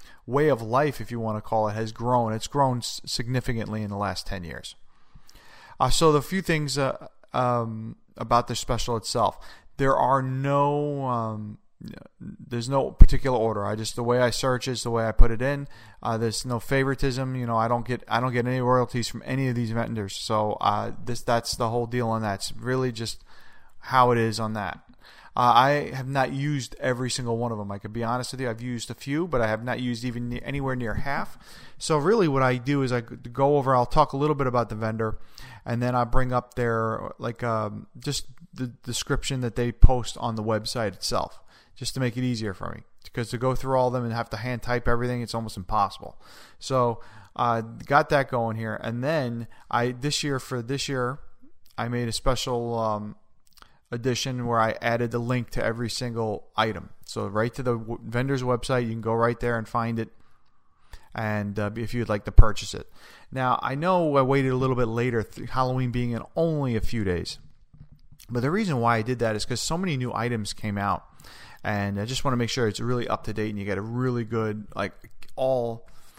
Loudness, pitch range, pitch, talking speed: -26 LUFS, 110-130 Hz, 120 Hz, 220 wpm